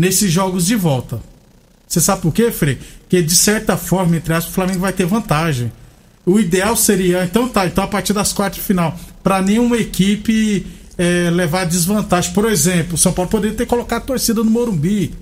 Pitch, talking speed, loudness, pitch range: 190 Hz, 195 wpm, -16 LUFS, 175-210 Hz